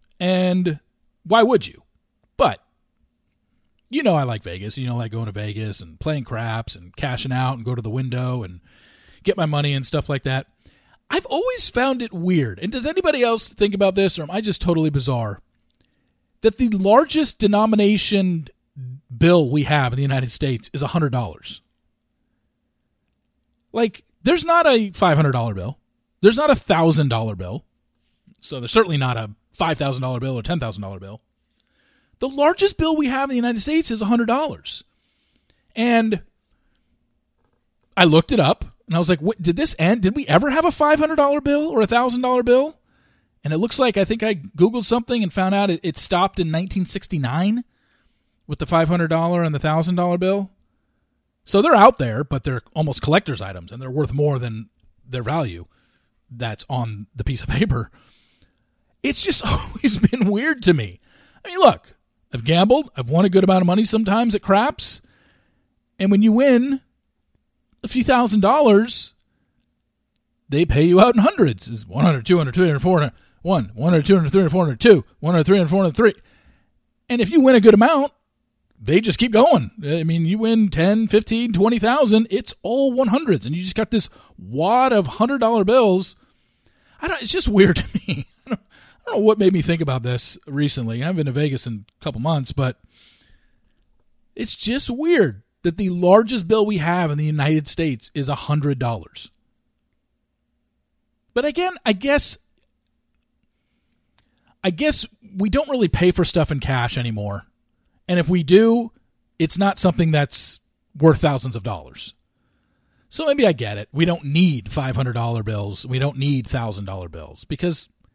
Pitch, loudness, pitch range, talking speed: 175 Hz, -19 LUFS, 130-220 Hz, 175 wpm